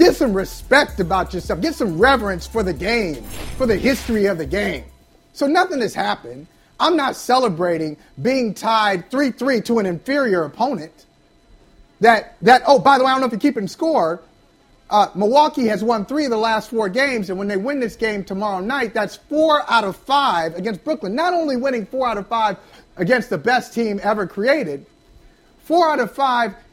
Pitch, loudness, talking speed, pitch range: 230 Hz, -18 LUFS, 200 wpm, 205-270 Hz